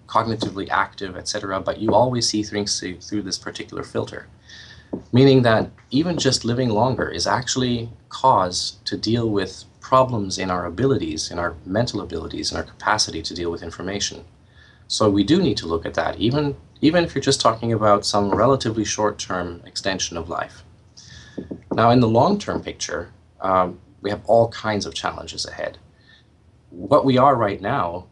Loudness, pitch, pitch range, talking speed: -21 LUFS, 105 Hz, 95-115 Hz, 170 wpm